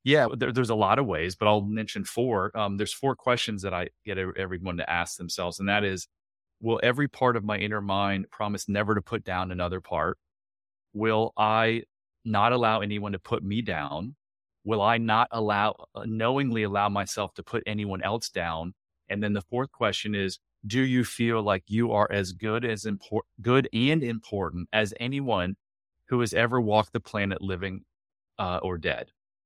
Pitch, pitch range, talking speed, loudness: 105 Hz, 95-115 Hz, 185 wpm, -27 LUFS